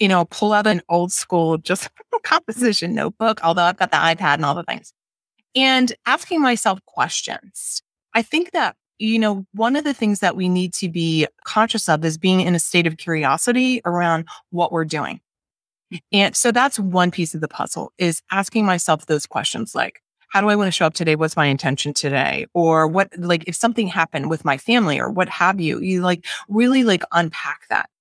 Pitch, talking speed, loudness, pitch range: 180 Hz, 205 wpm, -19 LUFS, 165-220 Hz